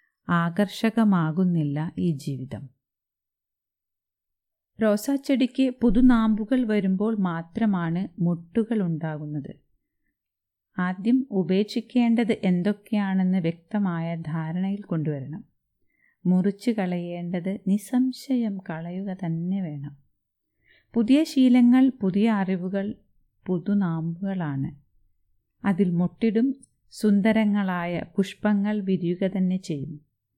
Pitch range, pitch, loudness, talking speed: 165-220 Hz, 190 Hz, -25 LUFS, 65 wpm